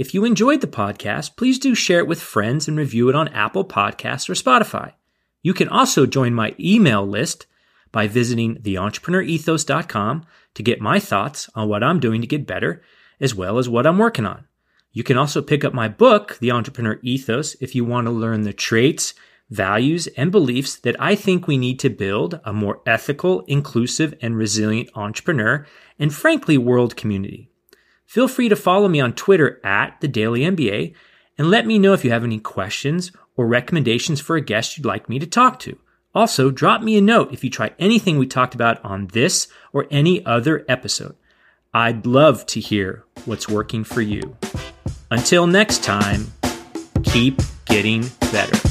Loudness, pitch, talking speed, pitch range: -18 LUFS, 130 Hz, 180 wpm, 110-165 Hz